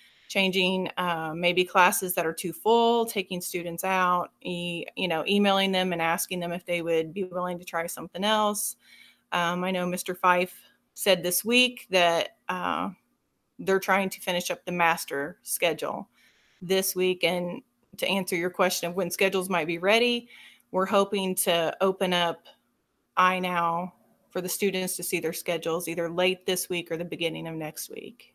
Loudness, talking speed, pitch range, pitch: -26 LUFS, 175 wpm, 175-190 Hz, 180 Hz